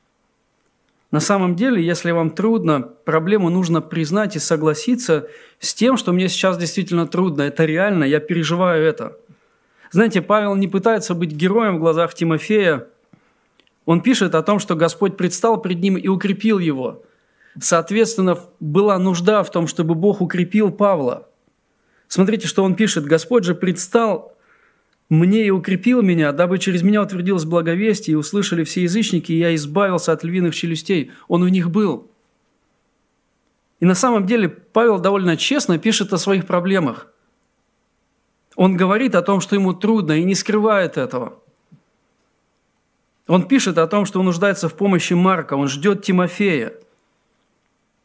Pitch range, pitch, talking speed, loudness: 170-205 Hz, 185 Hz, 145 wpm, -18 LUFS